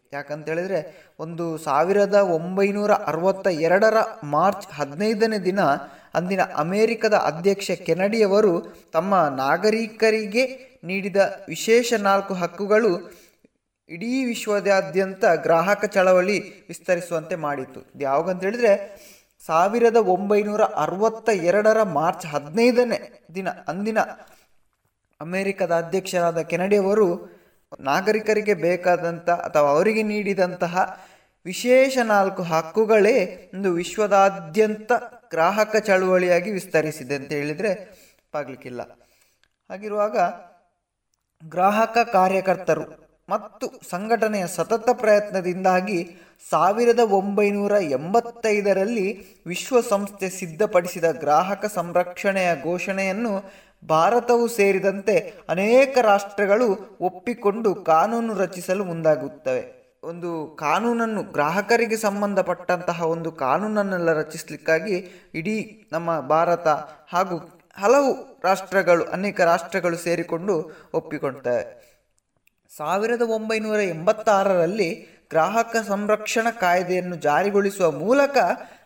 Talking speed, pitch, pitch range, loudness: 80 wpm, 195 Hz, 170-215 Hz, -22 LUFS